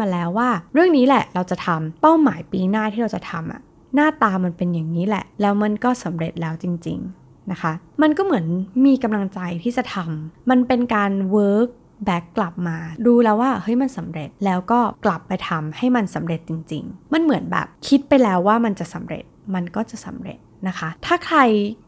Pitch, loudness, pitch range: 205 Hz, -20 LUFS, 175-245 Hz